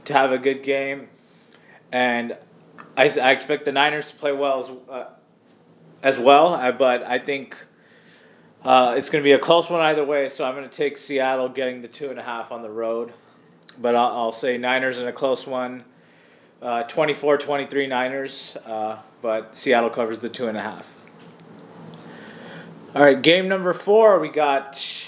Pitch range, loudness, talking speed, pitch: 120-145 Hz, -21 LUFS, 180 wpm, 135 Hz